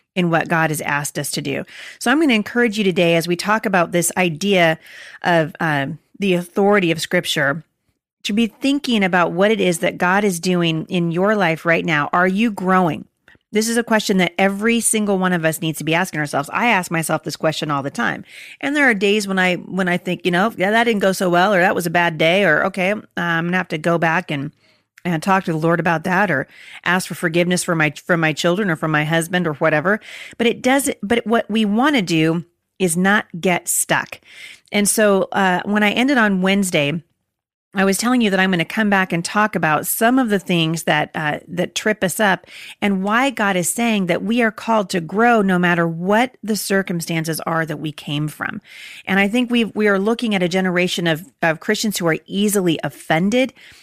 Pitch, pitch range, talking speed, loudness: 185 Hz, 165-210 Hz, 230 wpm, -18 LUFS